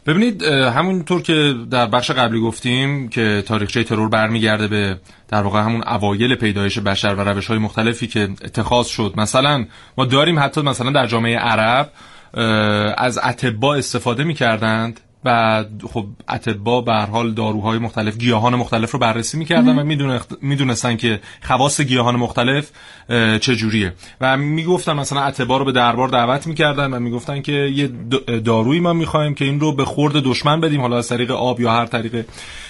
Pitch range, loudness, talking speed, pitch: 110-140 Hz, -17 LUFS, 160 wpm, 120 Hz